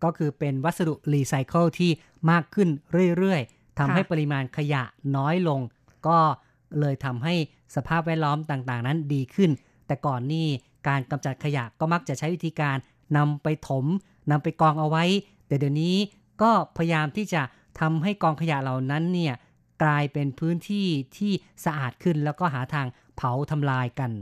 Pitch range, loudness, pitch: 135-170 Hz, -26 LUFS, 150 Hz